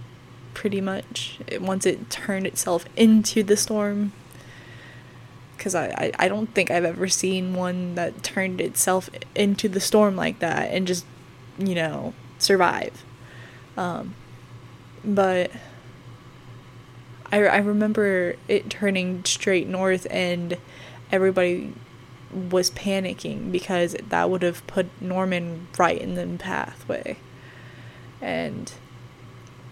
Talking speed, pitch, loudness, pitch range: 115 wpm, 175 Hz, -24 LUFS, 125-190 Hz